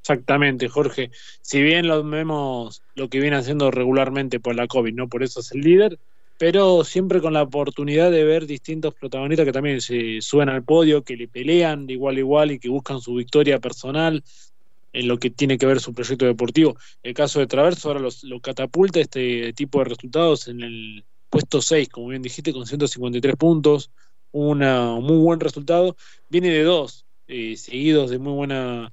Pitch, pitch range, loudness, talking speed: 140 Hz, 125-155 Hz, -20 LUFS, 185 wpm